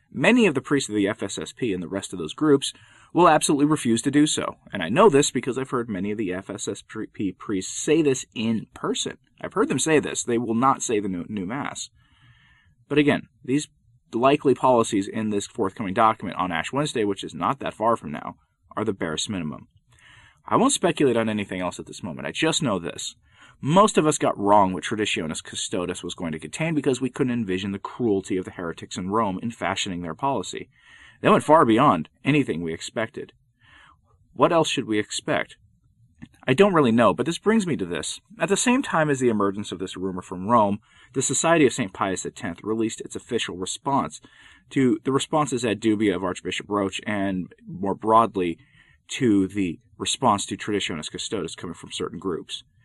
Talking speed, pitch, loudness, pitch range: 200 wpm, 110 Hz, -23 LUFS, 95-140 Hz